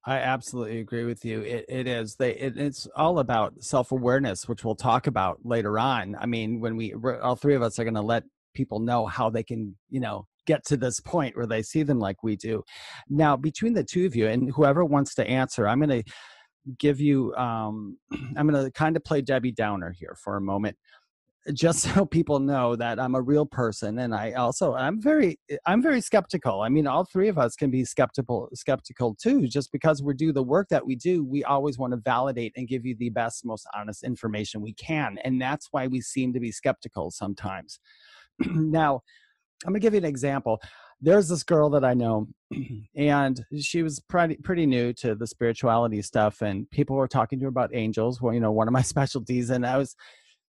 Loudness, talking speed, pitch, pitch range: -26 LUFS, 215 wpm, 130 Hz, 115-145 Hz